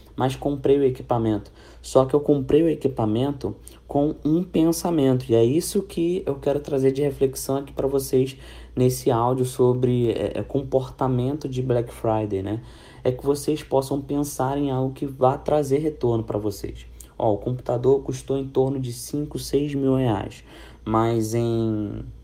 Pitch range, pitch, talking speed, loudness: 120-140 Hz, 130 Hz, 160 wpm, -23 LUFS